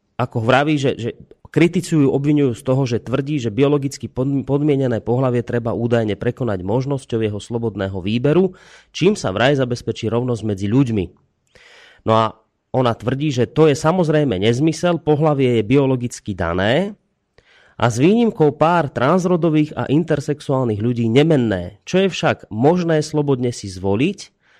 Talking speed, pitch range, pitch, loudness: 140 wpm, 115-150 Hz, 130 Hz, -18 LUFS